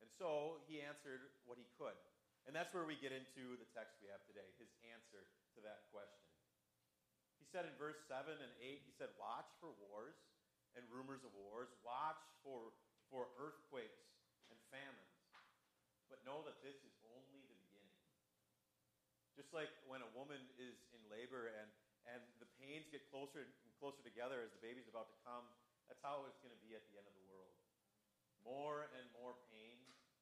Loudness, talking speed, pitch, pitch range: -55 LUFS, 185 wpm, 125 Hz, 115-140 Hz